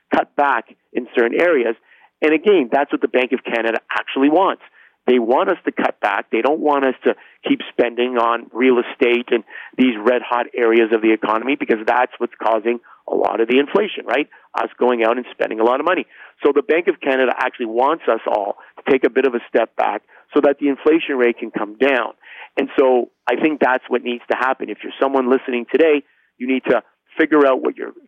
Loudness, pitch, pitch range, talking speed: -18 LUFS, 125 Hz, 120-145 Hz, 220 wpm